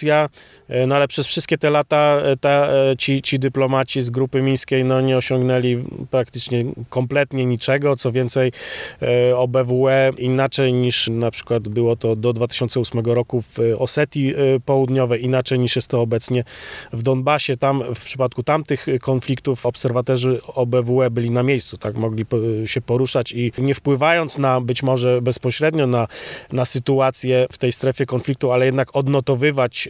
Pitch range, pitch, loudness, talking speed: 125-135 Hz, 130 Hz, -19 LUFS, 145 wpm